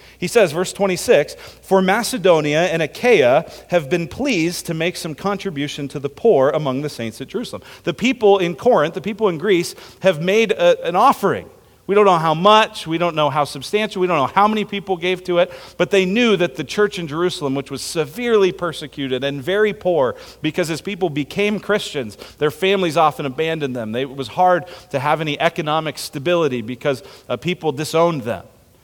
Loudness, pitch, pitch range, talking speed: -18 LUFS, 175 Hz, 150-195 Hz, 190 wpm